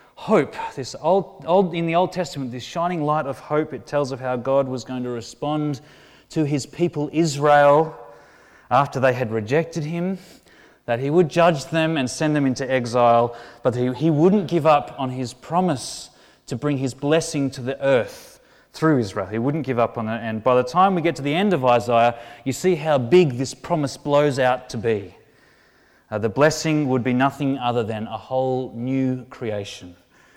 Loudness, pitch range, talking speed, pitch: -21 LUFS, 125-160 Hz, 195 wpm, 135 Hz